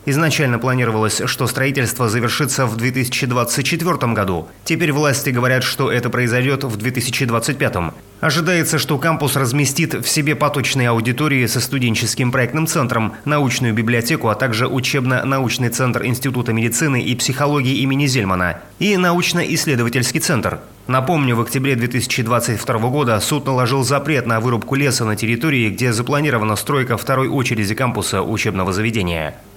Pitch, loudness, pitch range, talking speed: 130 Hz, -17 LUFS, 115-140 Hz, 130 wpm